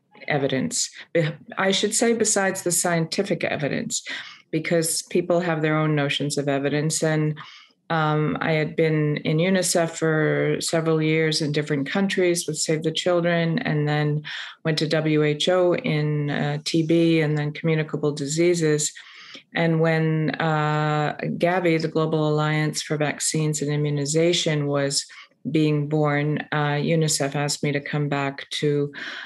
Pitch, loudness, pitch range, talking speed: 155 Hz, -22 LUFS, 150-165 Hz, 135 wpm